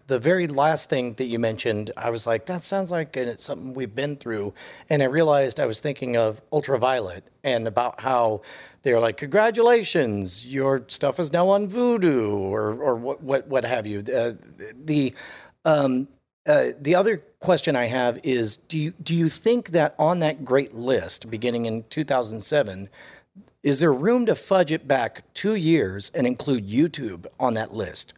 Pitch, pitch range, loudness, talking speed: 135 Hz, 115-165 Hz, -23 LUFS, 175 wpm